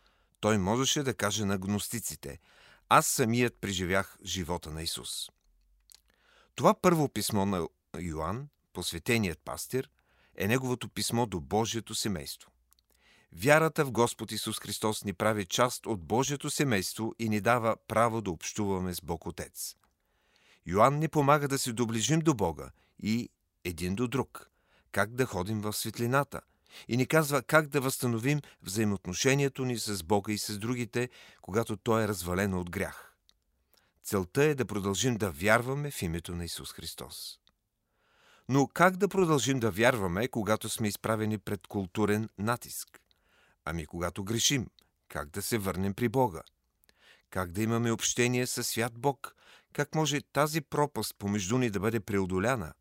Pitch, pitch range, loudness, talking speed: 110 Hz, 95-125 Hz, -30 LUFS, 145 wpm